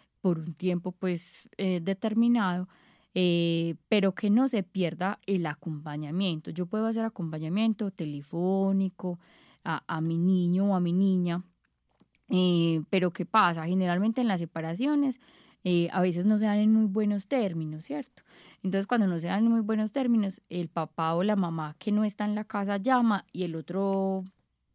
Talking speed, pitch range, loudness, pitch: 170 wpm, 175-215 Hz, -28 LUFS, 185 Hz